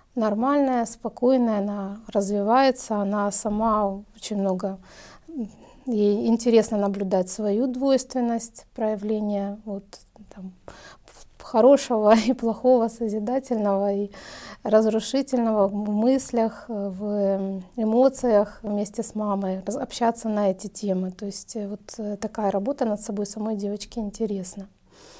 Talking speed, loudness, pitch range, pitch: 100 wpm, -24 LUFS, 200-230 Hz, 215 Hz